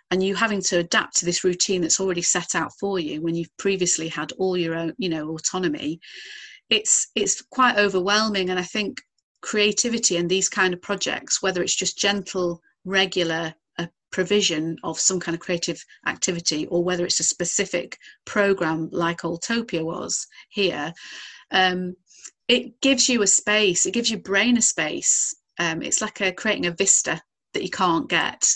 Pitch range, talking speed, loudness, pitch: 175-205 Hz, 175 wpm, -22 LUFS, 185 Hz